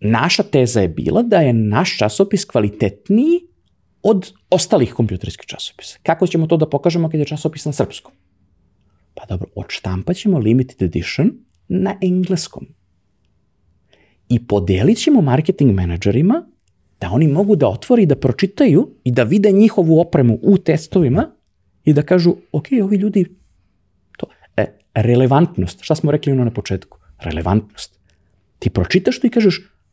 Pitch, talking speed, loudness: 135 Hz, 145 wpm, -16 LUFS